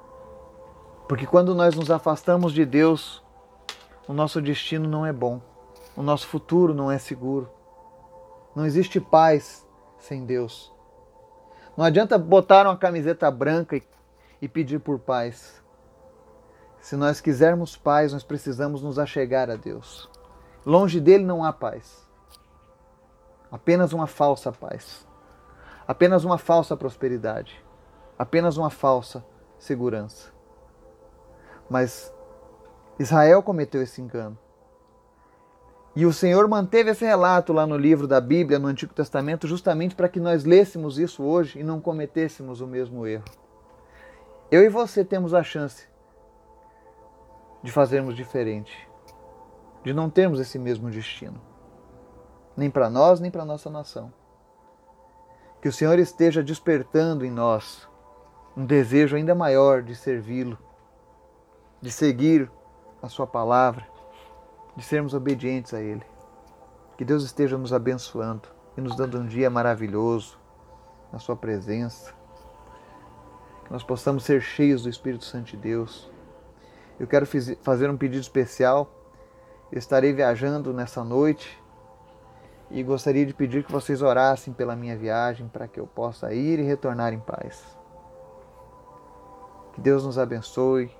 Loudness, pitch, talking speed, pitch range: -22 LUFS, 140 Hz, 130 wpm, 120-160 Hz